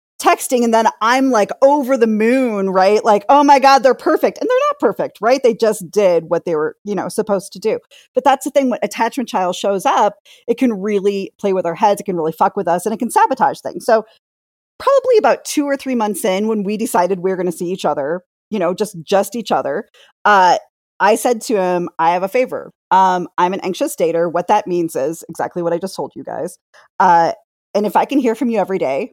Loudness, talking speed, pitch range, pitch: -16 LUFS, 240 wpm, 185-255 Hz, 210 Hz